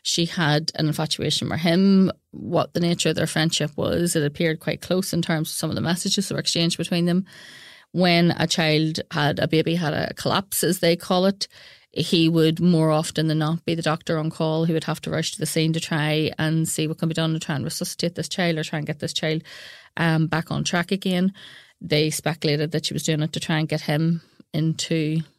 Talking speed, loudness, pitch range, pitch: 235 wpm, -22 LUFS, 155-170 Hz, 160 Hz